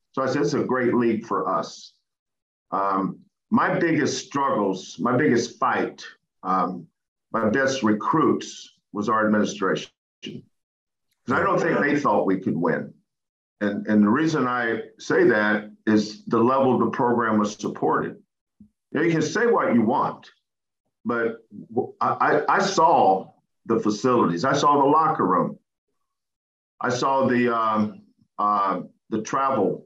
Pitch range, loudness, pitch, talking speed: 105-135 Hz, -22 LUFS, 115 Hz, 145 wpm